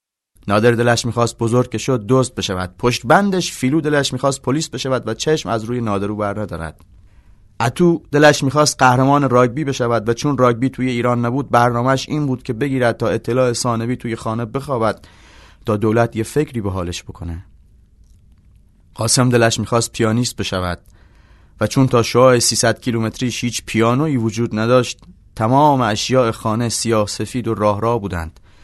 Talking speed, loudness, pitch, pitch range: 160 wpm, -17 LUFS, 115 Hz, 105-130 Hz